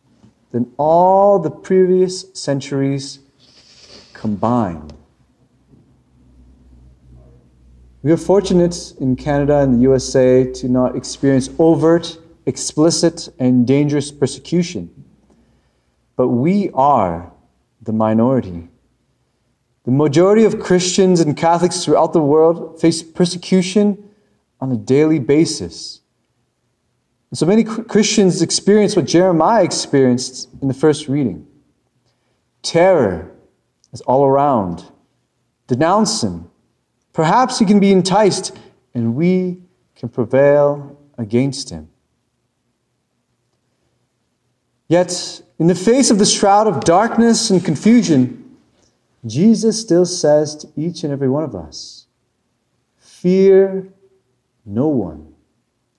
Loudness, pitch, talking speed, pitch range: -15 LUFS, 145 Hz, 100 wpm, 125-180 Hz